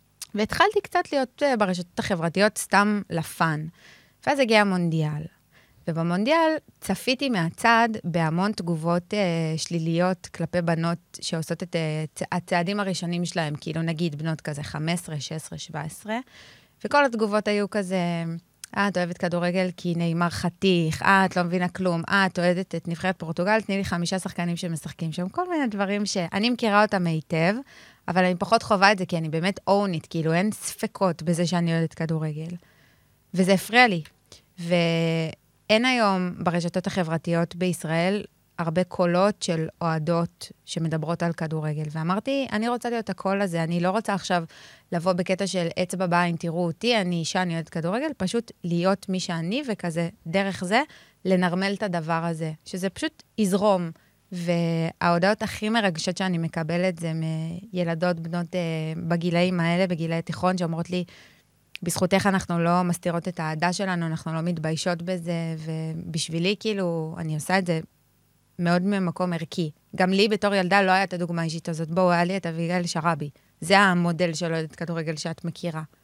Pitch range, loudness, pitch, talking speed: 165-195 Hz, -25 LUFS, 175 Hz, 155 wpm